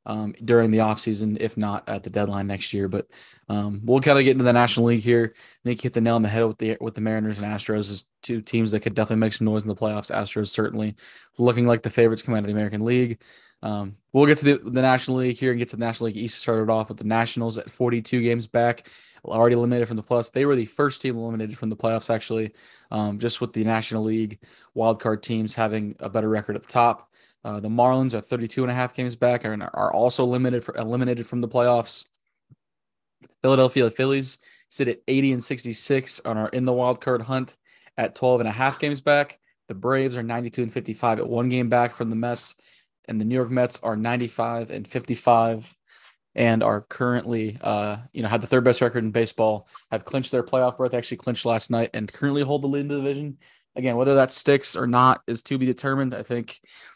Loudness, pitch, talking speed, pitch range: -23 LUFS, 120 Hz, 235 wpm, 110-125 Hz